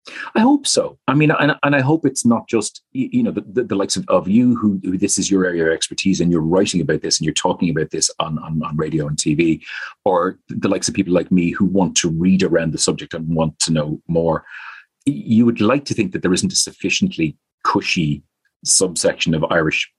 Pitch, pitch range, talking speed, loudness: 95 Hz, 80-130 Hz, 235 wpm, -18 LUFS